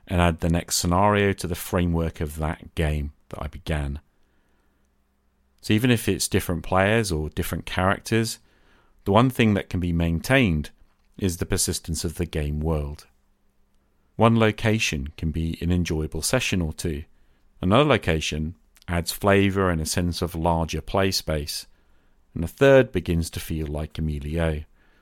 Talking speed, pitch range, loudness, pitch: 160 wpm, 75-95 Hz, -24 LUFS, 85 Hz